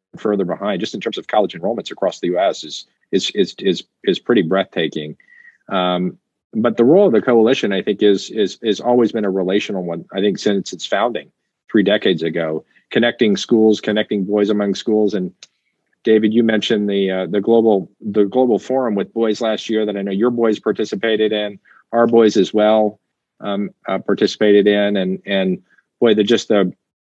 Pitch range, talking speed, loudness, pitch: 100-110 Hz, 190 wpm, -17 LUFS, 105 Hz